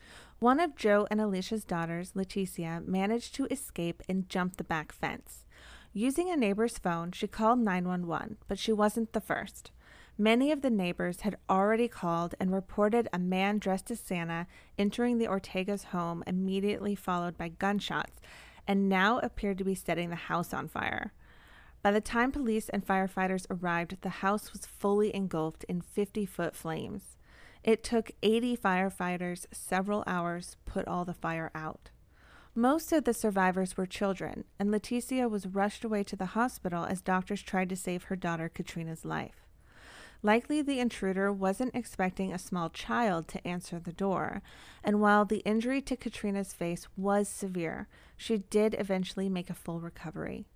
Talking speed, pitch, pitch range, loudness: 165 wpm, 195 Hz, 175-215 Hz, -32 LUFS